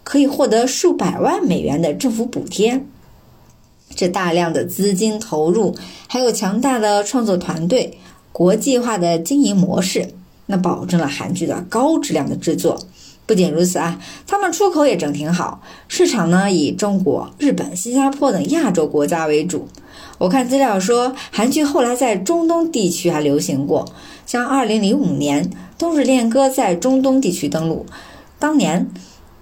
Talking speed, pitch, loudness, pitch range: 245 characters per minute, 220 Hz, -17 LUFS, 175-270 Hz